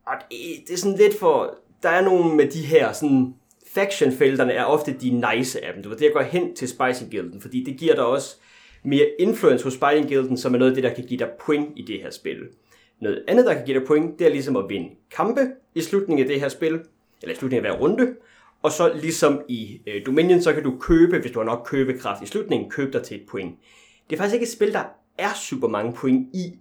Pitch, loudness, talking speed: 160 Hz, -22 LUFS, 245 wpm